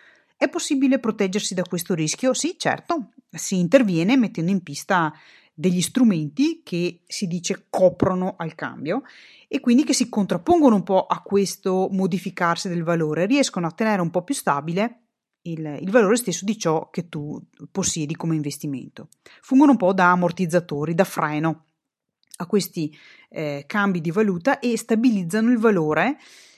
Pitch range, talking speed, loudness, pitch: 170-230 Hz, 155 wpm, -22 LUFS, 190 Hz